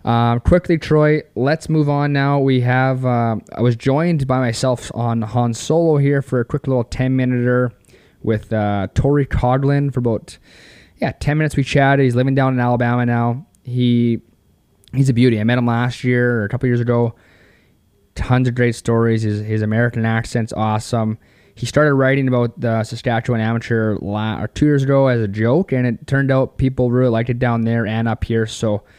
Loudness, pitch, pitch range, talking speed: -17 LUFS, 120 Hz, 115-135 Hz, 190 wpm